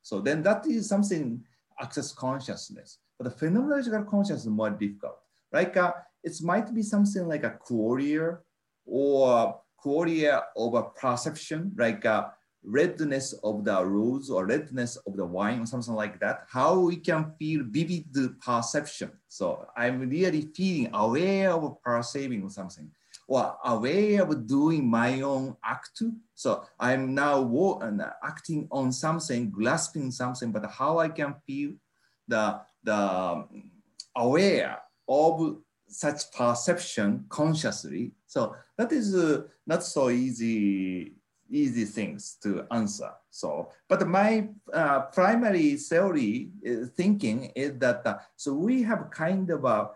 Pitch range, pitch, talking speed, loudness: 125-180 Hz, 150 Hz, 135 wpm, -28 LUFS